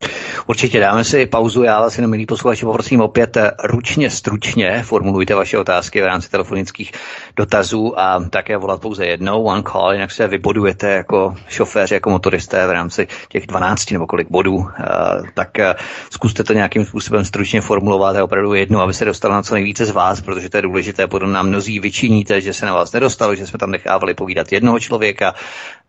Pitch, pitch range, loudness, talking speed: 105 Hz, 95-115 Hz, -15 LUFS, 185 wpm